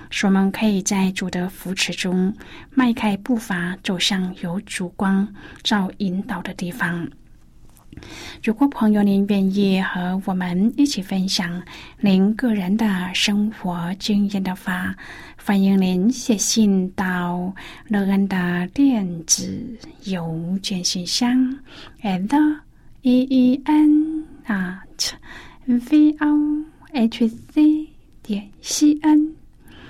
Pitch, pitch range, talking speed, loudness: 200 Hz, 185-245 Hz, 165 characters per minute, -20 LUFS